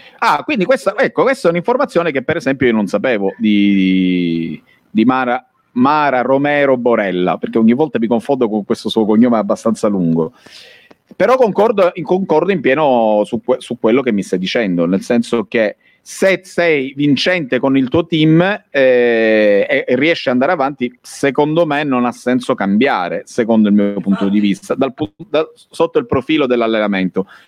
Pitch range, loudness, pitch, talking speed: 105-155 Hz, -14 LUFS, 125 Hz, 170 wpm